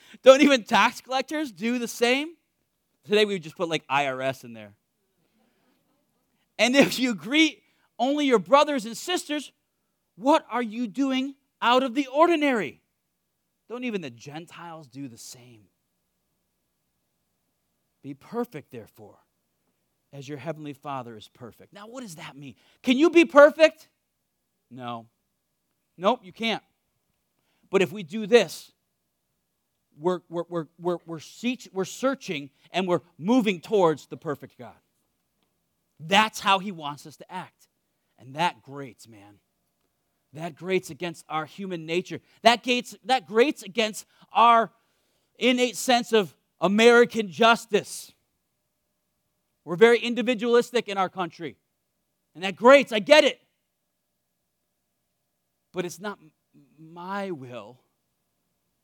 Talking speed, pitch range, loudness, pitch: 125 wpm, 145-240 Hz, -23 LUFS, 190 Hz